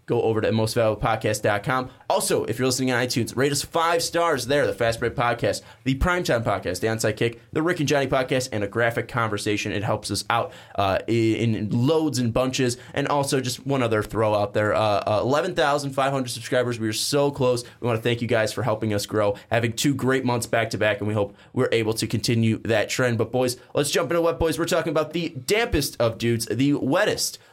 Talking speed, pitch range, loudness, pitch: 220 wpm, 110-140 Hz, -23 LUFS, 120 Hz